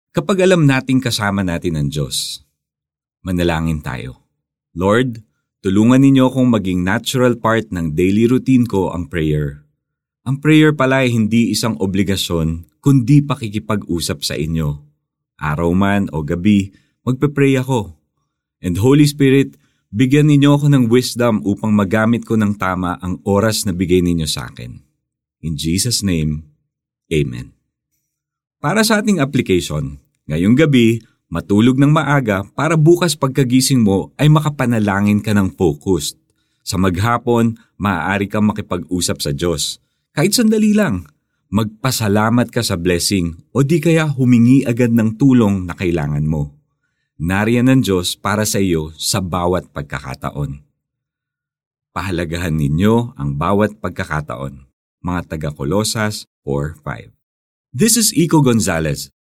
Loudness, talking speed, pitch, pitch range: -16 LUFS, 130 wpm, 105 Hz, 85-130 Hz